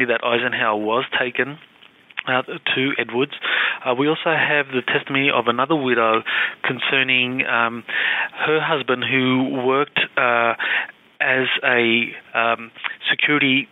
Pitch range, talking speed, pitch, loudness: 120-140 Hz, 120 wpm, 130 Hz, -19 LUFS